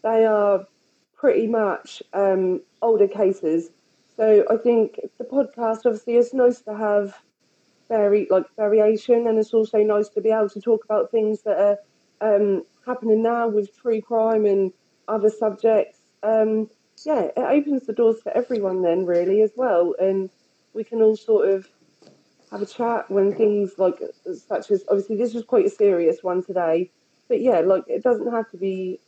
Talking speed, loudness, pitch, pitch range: 175 wpm, -21 LUFS, 215 Hz, 200-235 Hz